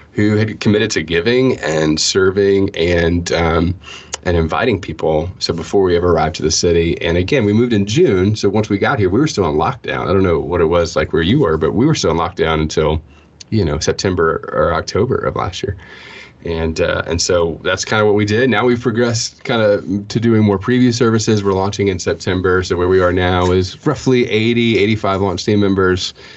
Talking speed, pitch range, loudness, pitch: 220 wpm, 85-110 Hz, -15 LUFS, 95 Hz